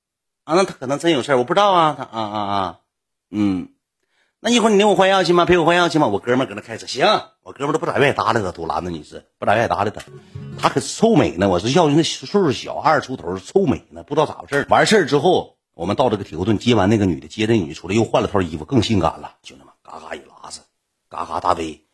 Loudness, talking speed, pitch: -18 LUFS, 385 characters per minute, 120 Hz